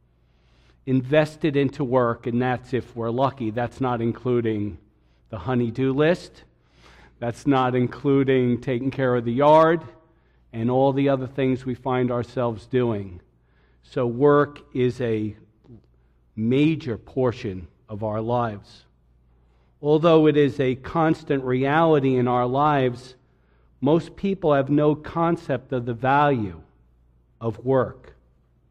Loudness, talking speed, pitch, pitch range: -22 LUFS, 125 wpm, 125 Hz, 110-140 Hz